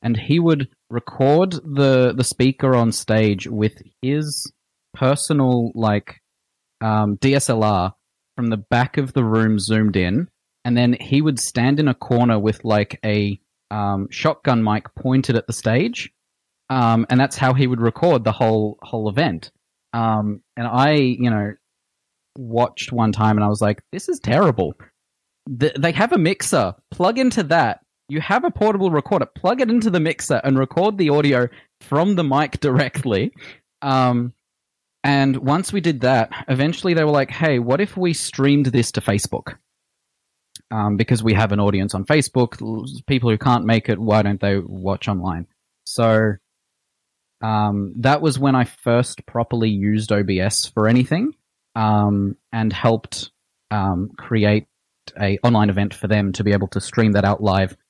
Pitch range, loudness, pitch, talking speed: 105-140 Hz, -19 LUFS, 120 Hz, 165 wpm